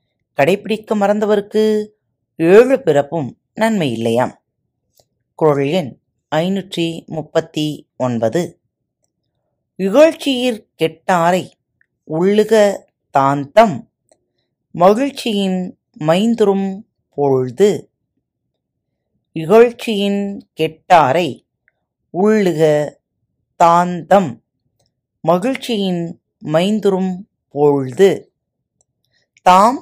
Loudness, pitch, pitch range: -15 LUFS, 180 Hz, 150-210 Hz